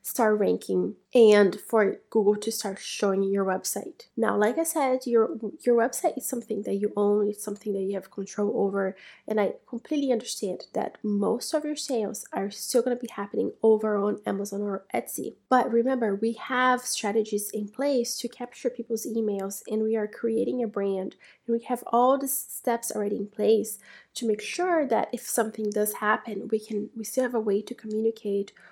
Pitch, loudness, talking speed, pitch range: 220 Hz, -27 LUFS, 190 wpm, 205-240 Hz